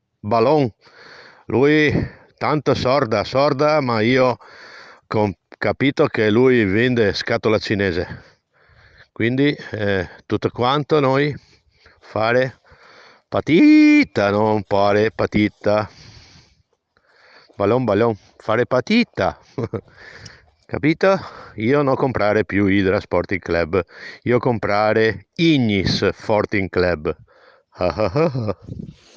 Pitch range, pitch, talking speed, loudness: 105-140 Hz, 115 Hz, 85 wpm, -18 LUFS